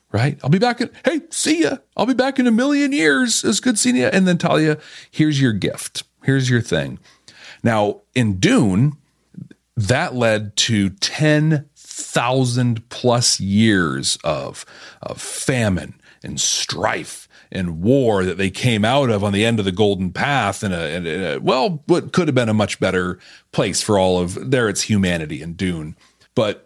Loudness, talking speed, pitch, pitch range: -18 LUFS, 175 wpm, 125 Hz, 100-155 Hz